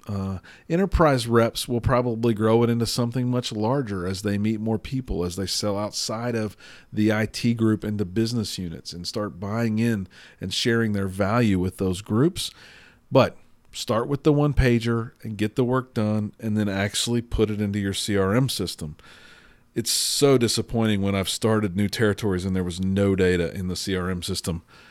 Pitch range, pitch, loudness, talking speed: 95-115 Hz, 105 Hz, -24 LUFS, 180 wpm